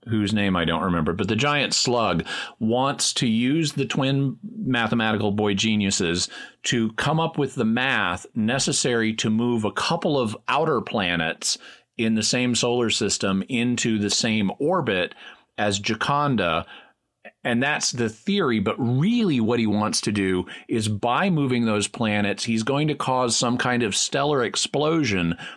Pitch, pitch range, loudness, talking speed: 115 Hz, 105-135 Hz, -22 LUFS, 155 wpm